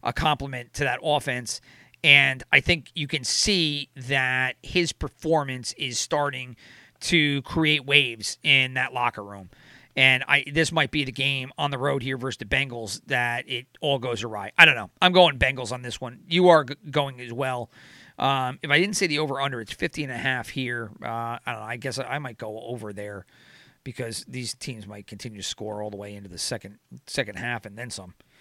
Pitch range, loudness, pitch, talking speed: 120-145 Hz, -23 LUFS, 130 Hz, 200 wpm